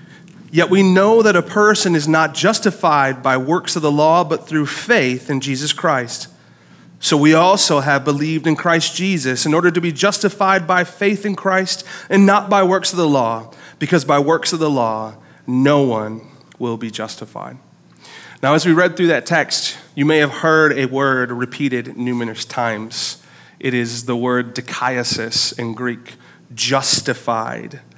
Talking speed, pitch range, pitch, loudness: 170 wpm, 125-180 Hz, 150 Hz, -16 LUFS